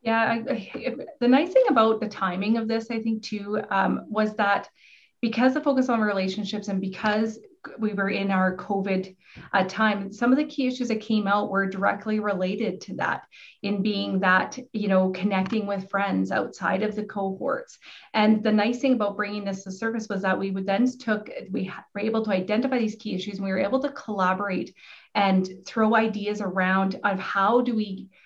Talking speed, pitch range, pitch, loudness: 195 wpm, 195-225 Hz, 210 Hz, -25 LUFS